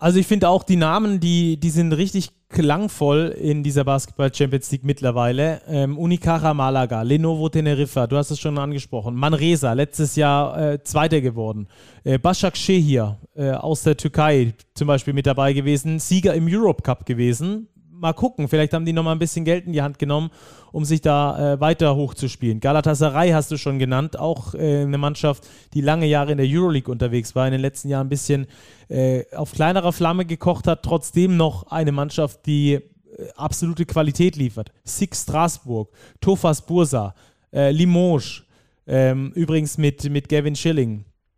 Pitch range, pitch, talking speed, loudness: 135-165 Hz, 150 Hz, 170 wpm, -20 LUFS